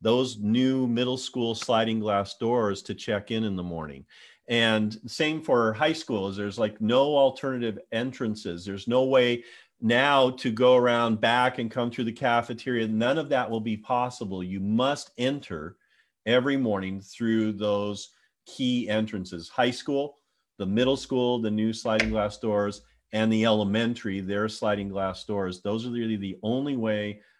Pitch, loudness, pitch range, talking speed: 115 Hz, -26 LUFS, 105-125 Hz, 160 wpm